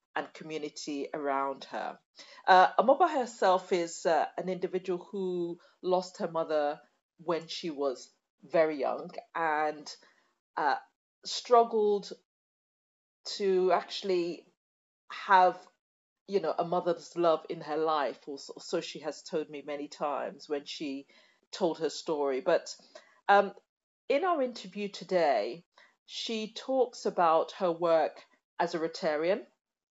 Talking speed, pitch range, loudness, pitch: 120 wpm, 155-200 Hz, -30 LUFS, 175 Hz